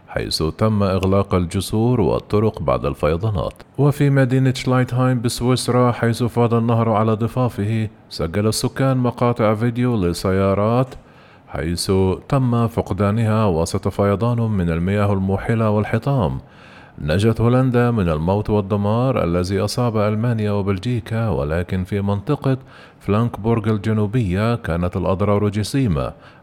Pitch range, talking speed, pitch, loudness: 100-120 Hz, 105 wpm, 110 Hz, -19 LUFS